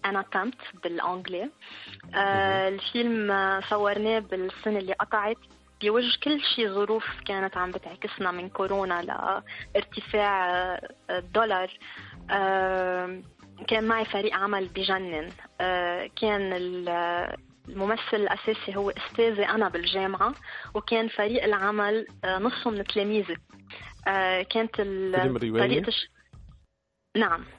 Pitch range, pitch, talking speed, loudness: 180-215 Hz, 195 Hz, 95 wpm, -27 LUFS